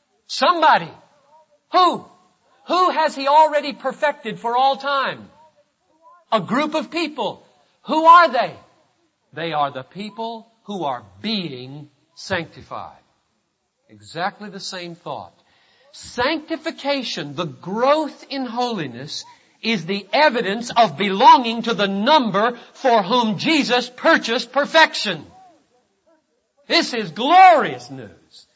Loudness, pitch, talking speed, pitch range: -18 LUFS, 250 Hz, 105 wpm, 200-310 Hz